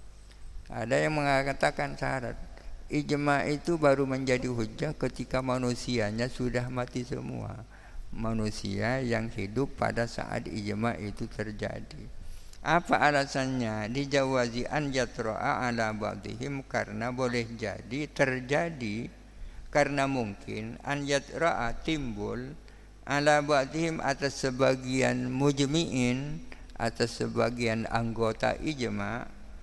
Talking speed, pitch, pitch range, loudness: 95 wpm, 125 Hz, 110-135 Hz, -30 LUFS